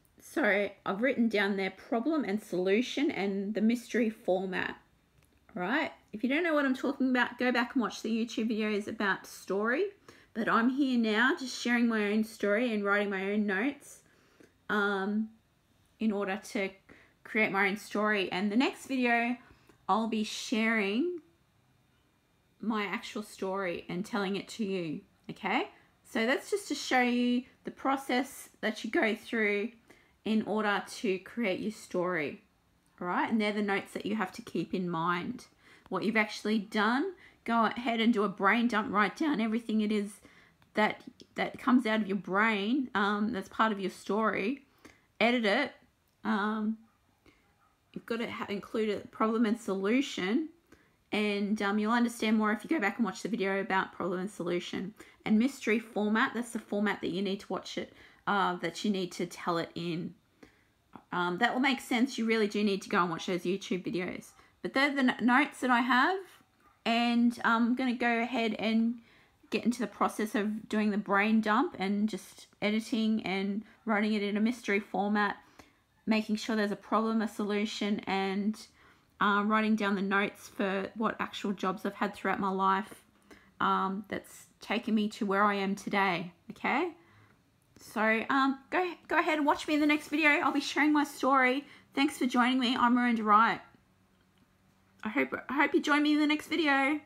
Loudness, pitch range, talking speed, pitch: -30 LUFS, 200-250 Hz, 180 wpm, 220 Hz